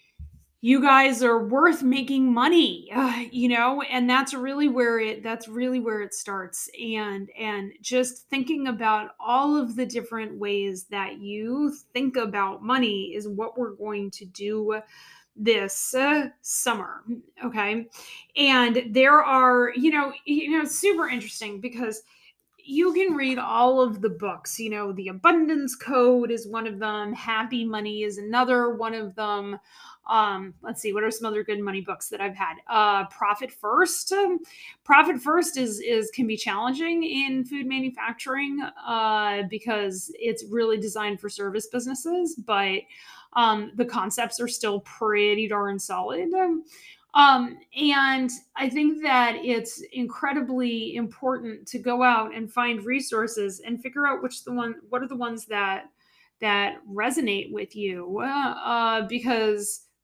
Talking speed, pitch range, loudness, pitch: 155 wpm, 215-265 Hz, -24 LUFS, 235 Hz